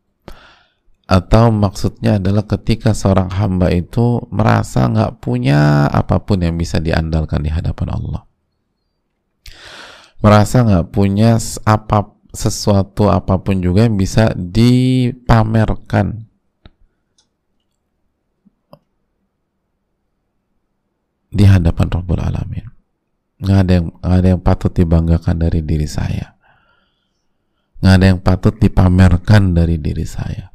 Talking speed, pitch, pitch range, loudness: 100 wpm, 95 Hz, 90-110 Hz, -14 LUFS